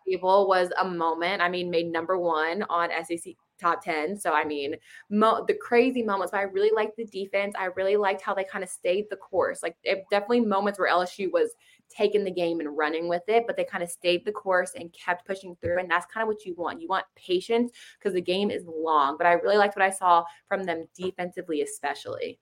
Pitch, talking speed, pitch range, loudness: 190 Hz, 230 wpm, 175-210 Hz, -26 LUFS